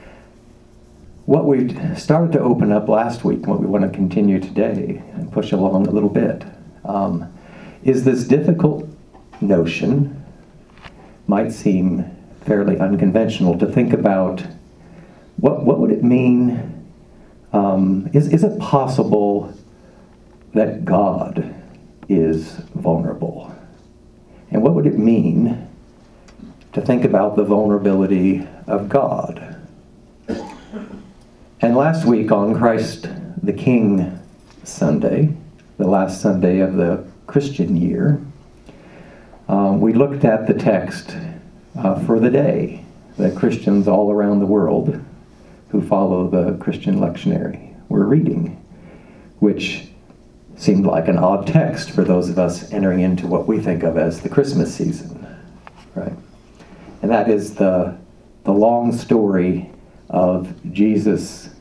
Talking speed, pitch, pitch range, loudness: 125 wpm, 105 Hz, 95-135 Hz, -17 LUFS